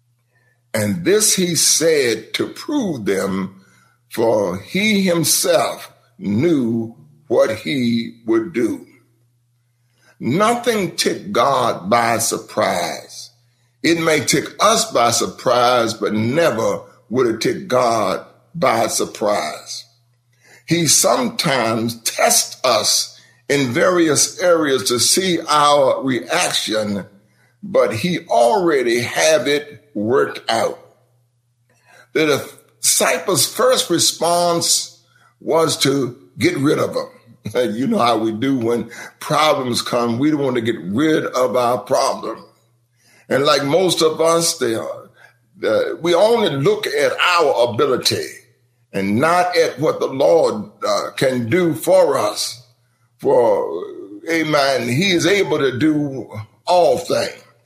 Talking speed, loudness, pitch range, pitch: 120 wpm, -17 LUFS, 120-180 Hz, 145 Hz